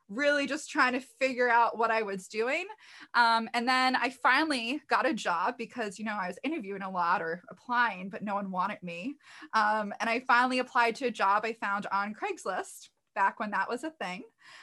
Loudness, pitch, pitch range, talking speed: -29 LUFS, 230 Hz, 205-255 Hz, 210 wpm